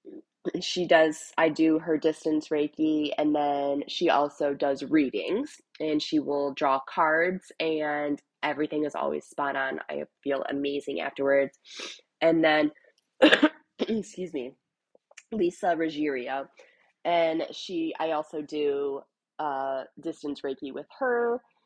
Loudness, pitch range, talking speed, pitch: -27 LUFS, 145-170 Hz, 120 wpm, 155 Hz